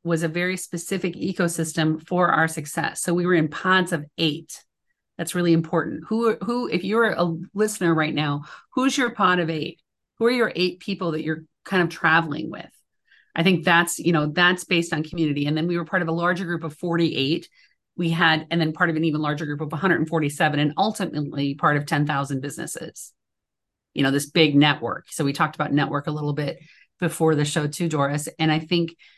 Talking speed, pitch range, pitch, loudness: 210 wpm, 155-175 Hz, 165 Hz, -23 LUFS